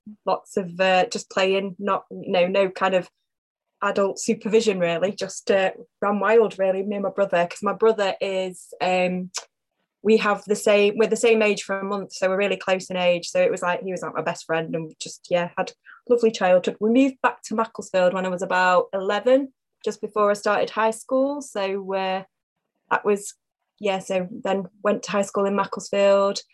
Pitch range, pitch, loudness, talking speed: 185-215 Hz, 200 Hz, -23 LUFS, 200 wpm